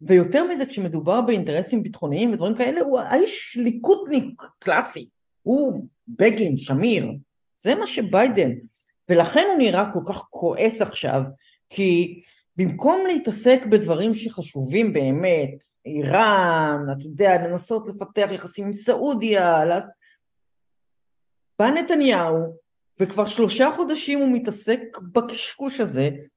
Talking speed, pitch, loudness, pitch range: 105 wpm, 210 Hz, -21 LUFS, 175-250 Hz